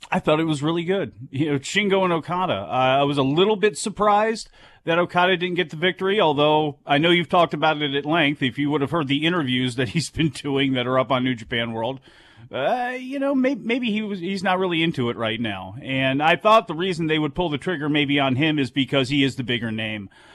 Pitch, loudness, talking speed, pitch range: 155 Hz, -21 LUFS, 250 wpm, 135-185 Hz